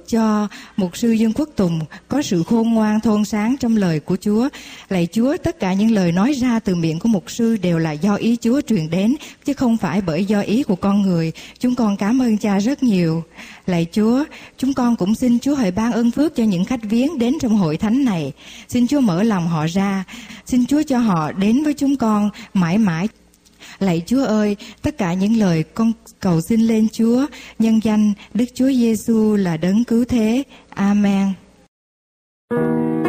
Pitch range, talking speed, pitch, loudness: 195-240 Hz, 200 wpm, 220 Hz, -18 LUFS